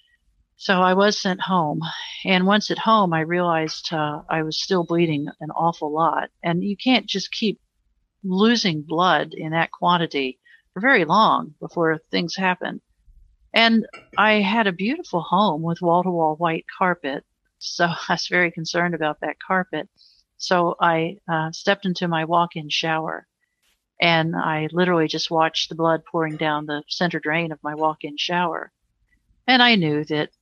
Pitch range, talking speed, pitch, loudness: 160-185 Hz, 160 wpm, 170 Hz, -21 LUFS